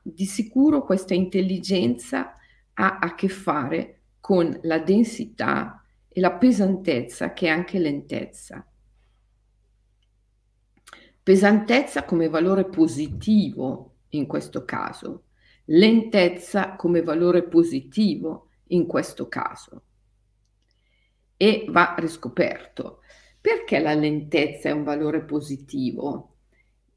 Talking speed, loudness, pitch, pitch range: 95 wpm, -22 LUFS, 170 Hz, 135-195 Hz